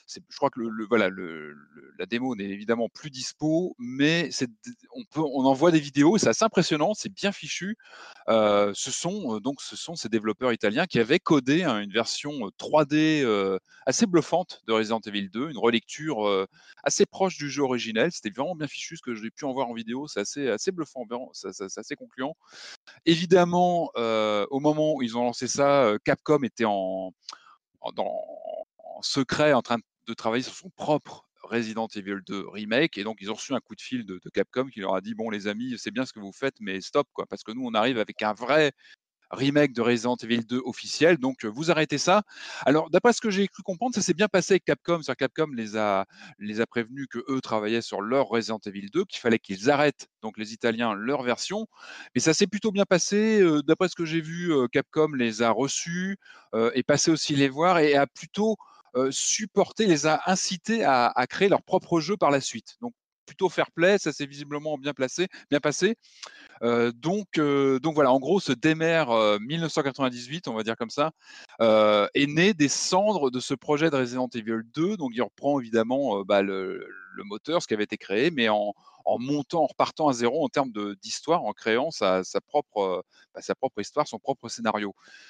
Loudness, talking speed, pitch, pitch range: -26 LUFS, 215 wpm, 140 Hz, 115-165 Hz